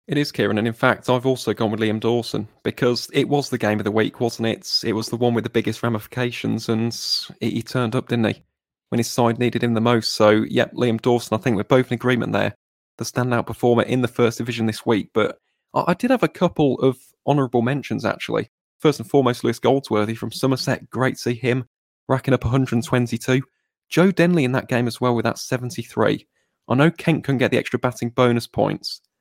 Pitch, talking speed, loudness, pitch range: 120 Hz, 220 wpm, -21 LUFS, 115-130 Hz